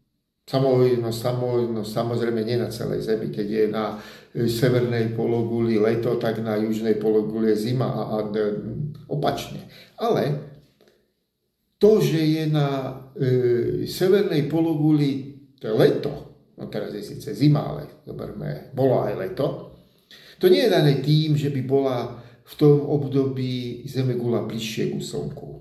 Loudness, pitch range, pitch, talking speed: -23 LUFS, 115-145 Hz, 125 Hz, 125 wpm